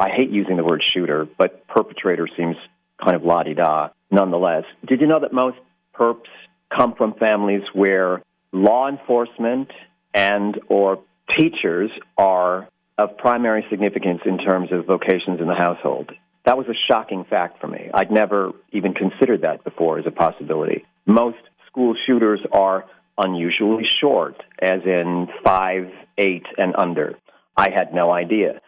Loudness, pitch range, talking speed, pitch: -19 LUFS, 90-115 Hz, 145 wpm, 100 Hz